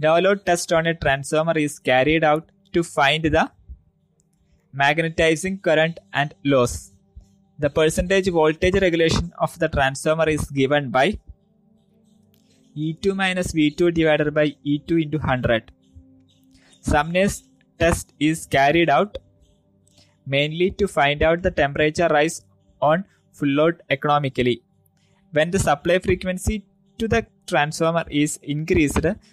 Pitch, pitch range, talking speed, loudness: 155 Hz, 135-175 Hz, 120 wpm, -20 LUFS